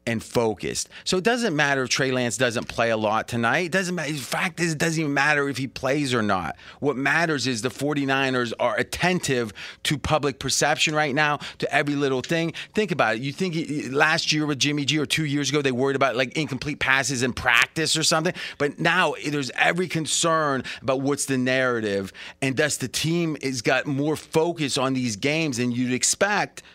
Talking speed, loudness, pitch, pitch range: 205 wpm, -23 LUFS, 145 Hz, 130-155 Hz